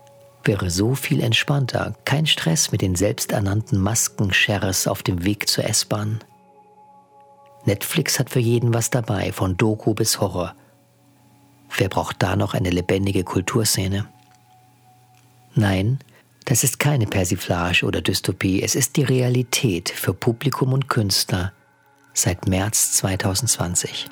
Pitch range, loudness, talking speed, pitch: 100-135 Hz, -20 LUFS, 125 wpm, 115 Hz